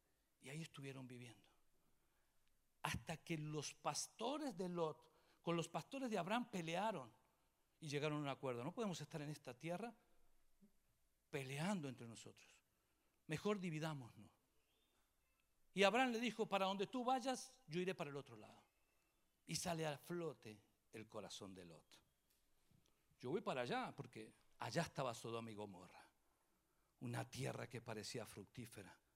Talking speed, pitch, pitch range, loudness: 140 wpm, 155 Hz, 115-185 Hz, -47 LUFS